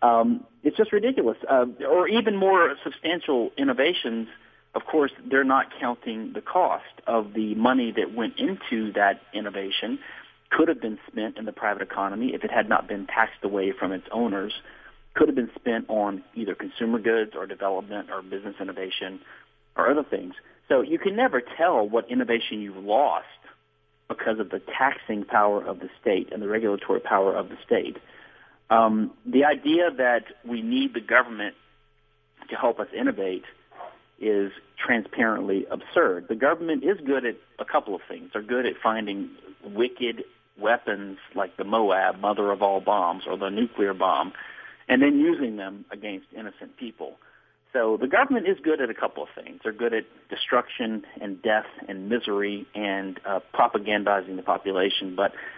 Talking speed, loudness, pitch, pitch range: 165 wpm, -25 LUFS, 115 Hz, 100-155 Hz